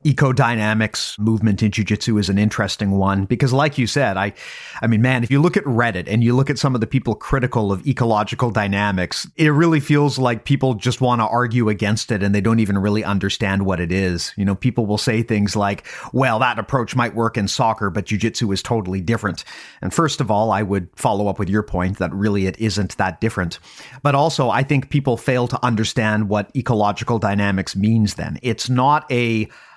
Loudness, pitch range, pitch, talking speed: -19 LUFS, 100-125 Hz, 110 Hz, 210 wpm